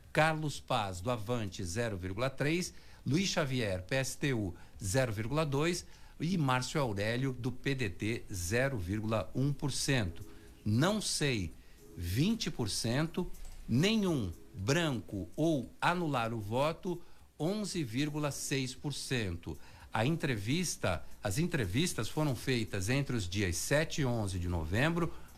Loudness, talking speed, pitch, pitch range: -34 LUFS, 90 wpm, 130 Hz, 105-155 Hz